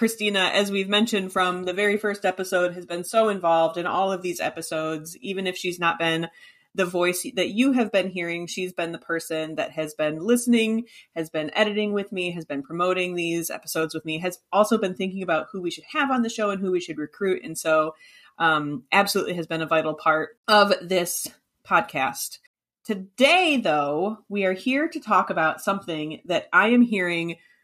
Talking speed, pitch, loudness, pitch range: 200 wpm, 180 Hz, -24 LUFS, 165-205 Hz